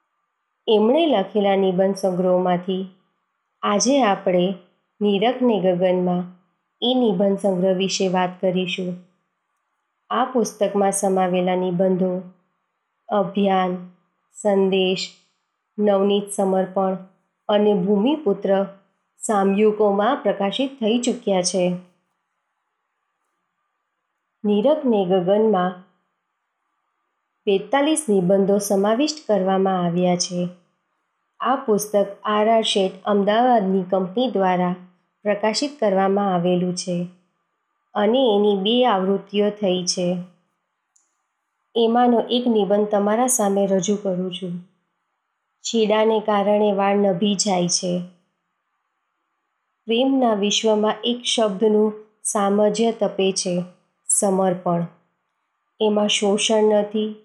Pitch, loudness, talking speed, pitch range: 195 Hz, -20 LUFS, 85 wpm, 185-215 Hz